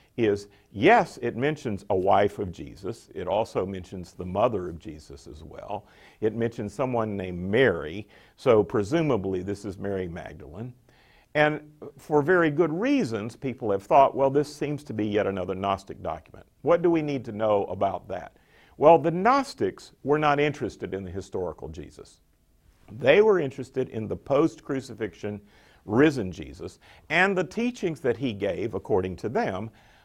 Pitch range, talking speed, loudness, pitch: 100-150 Hz, 160 wpm, -25 LUFS, 120 Hz